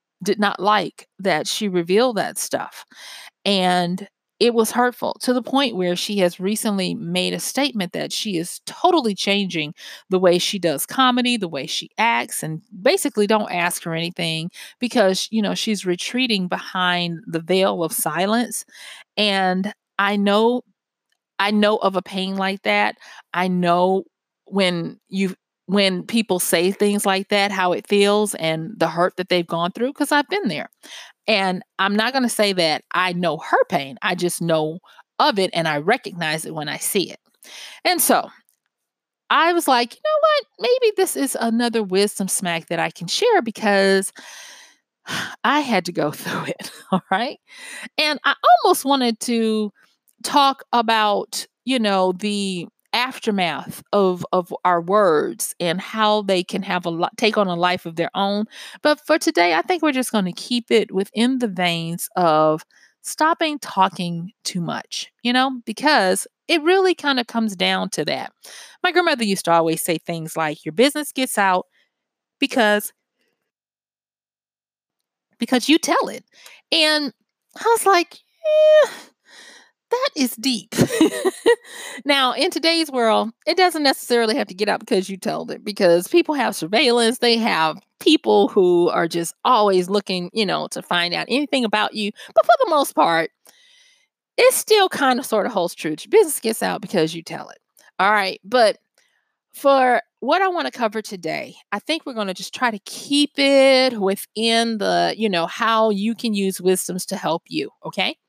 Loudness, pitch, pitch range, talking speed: -20 LUFS, 210 Hz, 180-260 Hz, 170 wpm